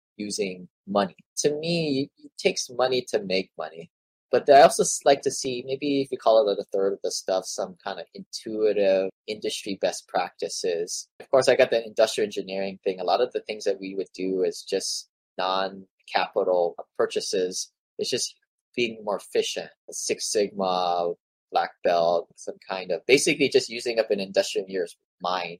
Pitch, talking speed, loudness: 170 Hz, 175 wpm, -25 LUFS